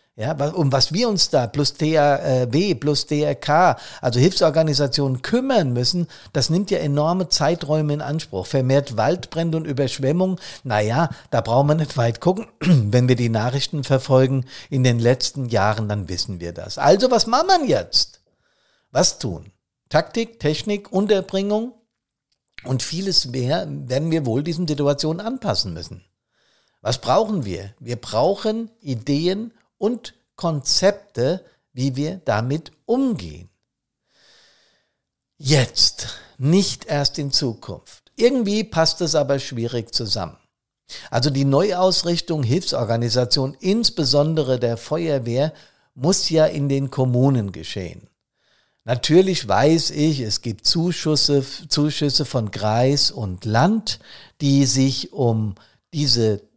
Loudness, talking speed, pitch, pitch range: -20 LUFS, 125 wpm, 145 Hz, 125-170 Hz